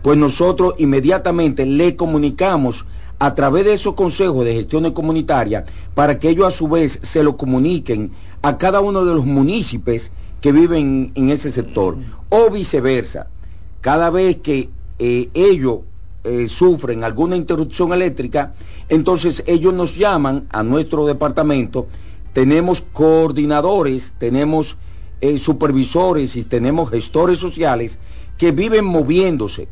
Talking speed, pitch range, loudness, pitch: 130 wpm, 120-170 Hz, -16 LUFS, 145 Hz